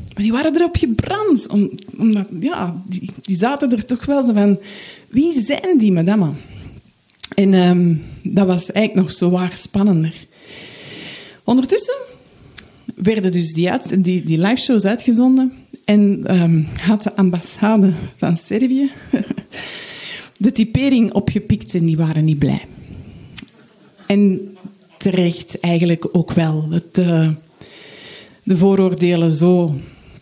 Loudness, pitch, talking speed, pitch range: -16 LUFS, 195 Hz, 120 wpm, 175-220 Hz